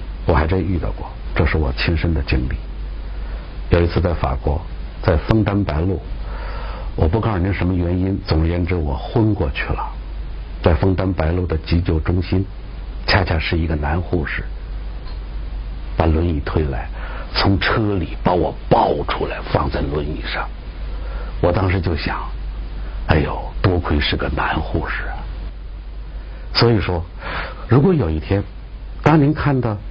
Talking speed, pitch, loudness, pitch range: 215 characters per minute, 85 Hz, -20 LUFS, 80-95 Hz